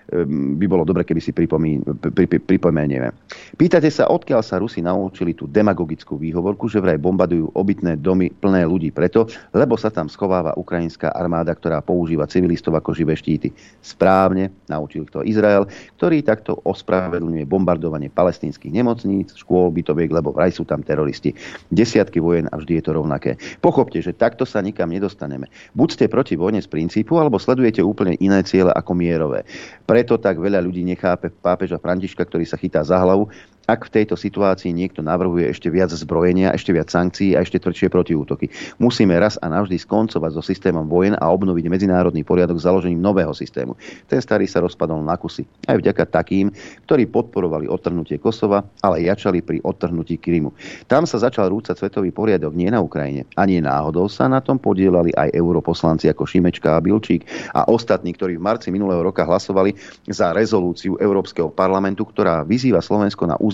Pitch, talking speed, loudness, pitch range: 90 Hz, 170 wpm, -19 LUFS, 85-95 Hz